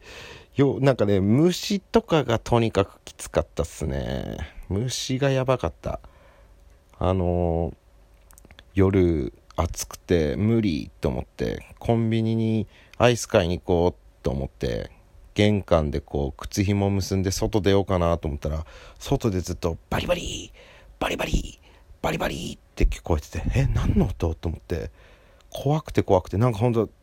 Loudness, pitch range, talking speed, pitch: -25 LUFS, 85-115 Hz, 285 characters per minute, 95 Hz